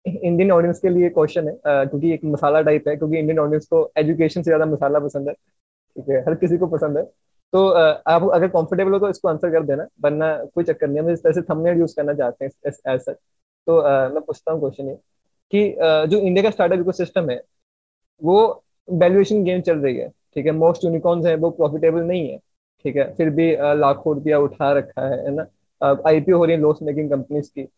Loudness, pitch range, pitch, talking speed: -19 LUFS, 145-175 Hz, 160 Hz, 210 wpm